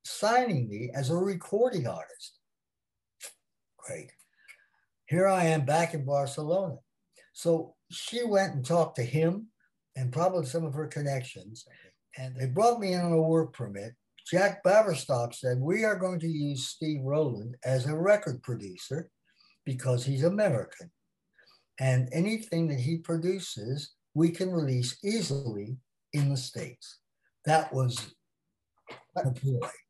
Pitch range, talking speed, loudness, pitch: 130-180 Hz, 135 wpm, -29 LUFS, 155 Hz